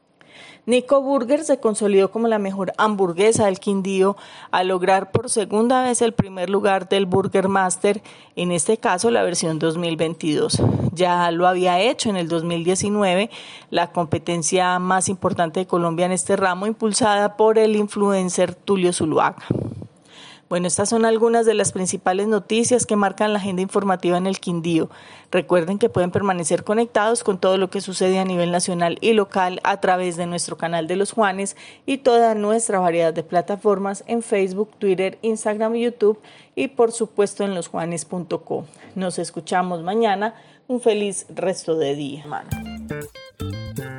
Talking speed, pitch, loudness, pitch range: 155 wpm, 190 Hz, -20 LUFS, 175-215 Hz